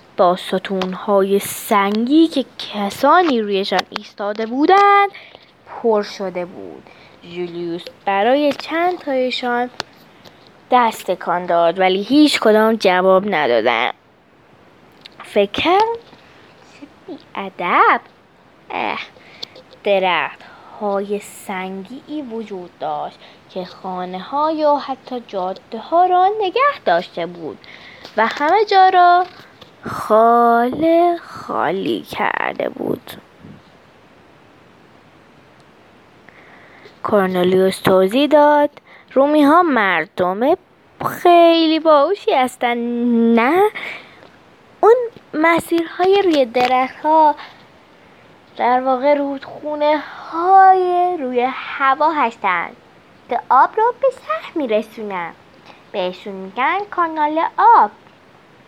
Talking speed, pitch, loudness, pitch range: 85 wpm, 250 Hz, -16 LUFS, 195-320 Hz